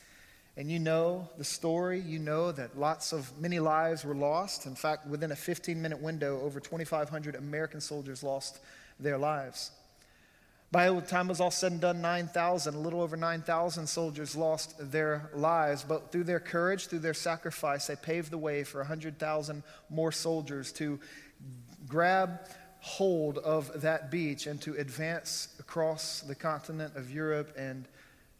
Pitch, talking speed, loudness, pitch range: 160 Hz, 160 wpm, -33 LUFS, 150-170 Hz